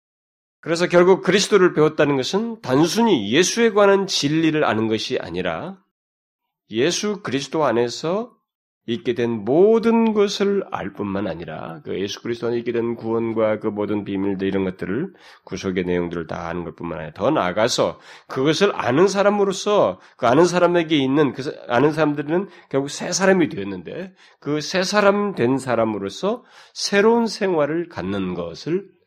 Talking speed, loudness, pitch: 330 characters per minute, -20 LUFS, 150 Hz